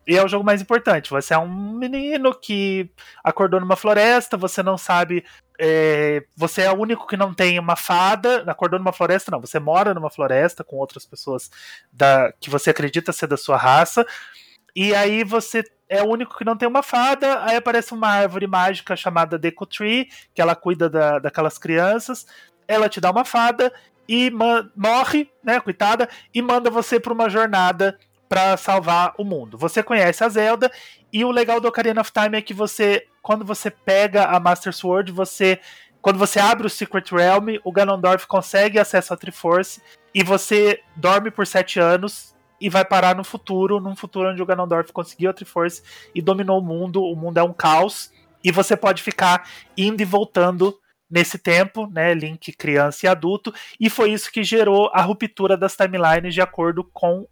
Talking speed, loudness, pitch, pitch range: 185 wpm, -19 LUFS, 195 Hz, 175-215 Hz